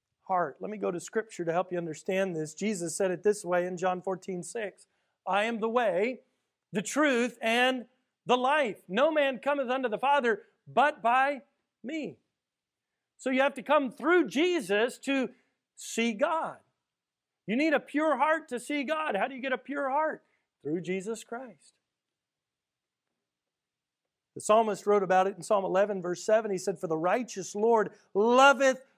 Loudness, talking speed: -29 LUFS, 170 wpm